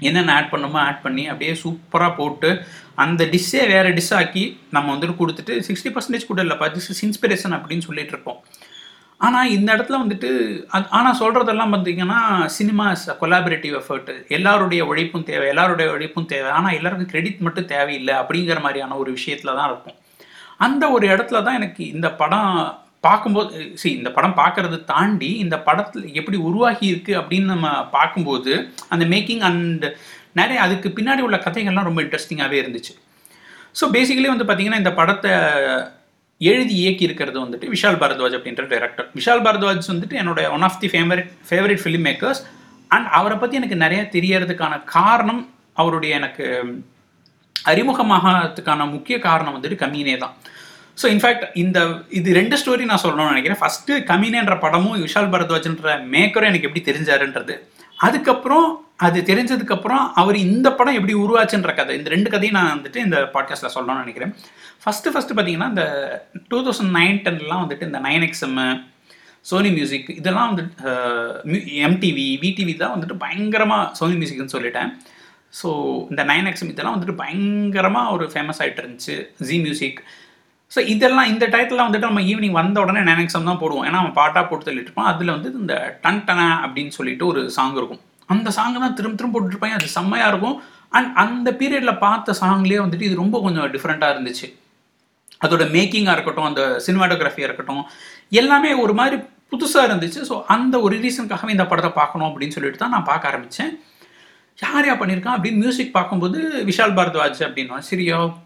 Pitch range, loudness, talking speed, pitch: 160-215 Hz, -18 LUFS, 155 wpm, 185 Hz